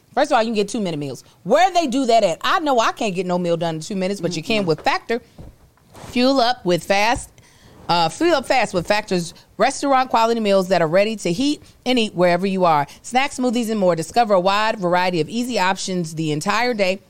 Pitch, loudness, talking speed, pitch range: 200 Hz, -19 LUFS, 235 wpm, 175-245 Hz